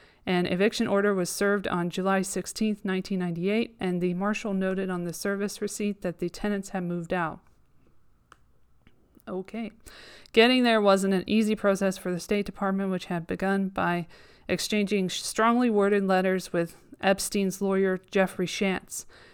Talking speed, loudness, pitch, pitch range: 145 wpm, -27 LUFS, 195 Hz, 180-205 Hz